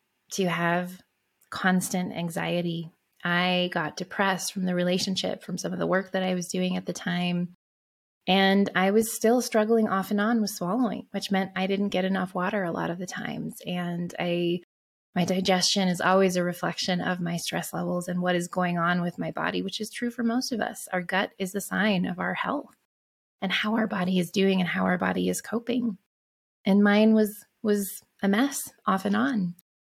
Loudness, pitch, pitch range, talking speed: -26 LUFS, 185 Hz, 180-205 Hz, 200 wpm